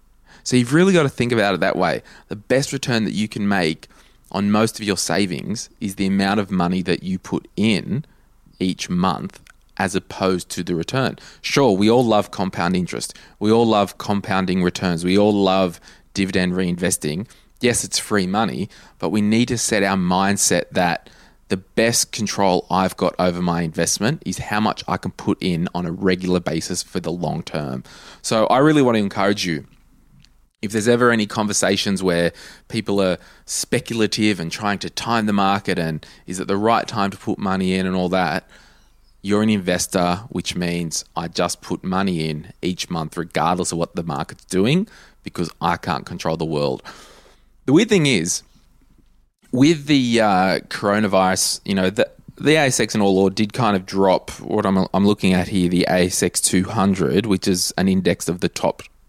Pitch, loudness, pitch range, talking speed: 95 Hz, -20 LUFS, 90-105 Hz, 185 wpm